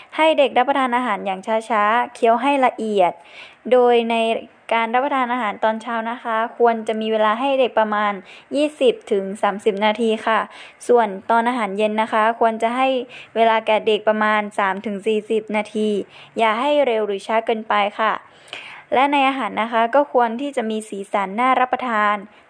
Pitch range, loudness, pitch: 215-245 Hz, -19 LUFS, 225 Hz